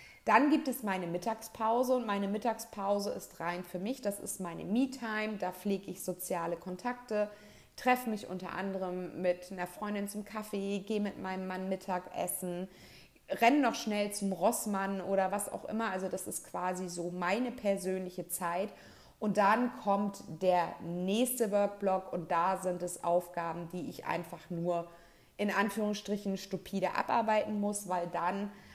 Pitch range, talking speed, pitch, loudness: 180-210 Hz, 155 wpm, 195 Hz, -34 LUFS